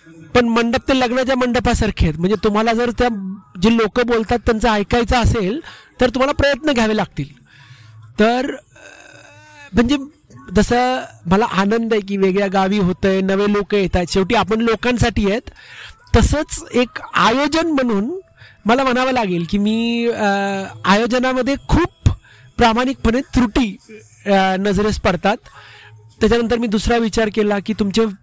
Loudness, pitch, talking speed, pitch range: -17 LUFS, 225 Hz, 130 wpm, 195-245 Hz